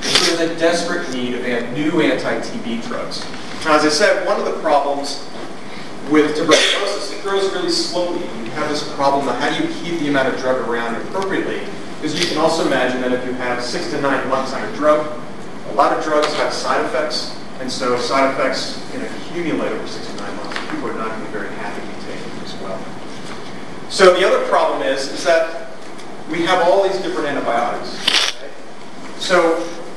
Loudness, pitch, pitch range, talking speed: -18 LUFS, 150 Hz, 130-170 Hz, 205 wpm